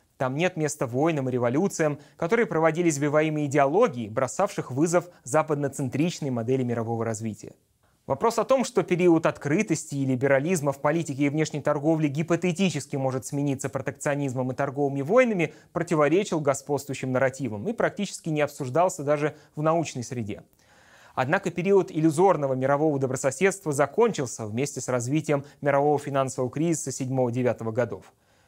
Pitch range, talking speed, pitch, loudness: 135-165 Hz, 130 wpm, 145 Hz, -25 LUFS